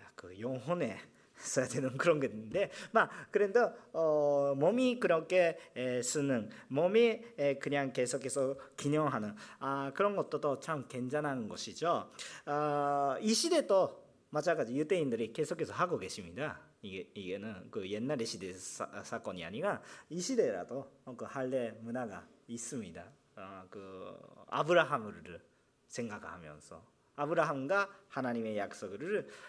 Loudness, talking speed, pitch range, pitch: -35 LUFS, 265 characters per minute, 130-165 Hz, 140 Hz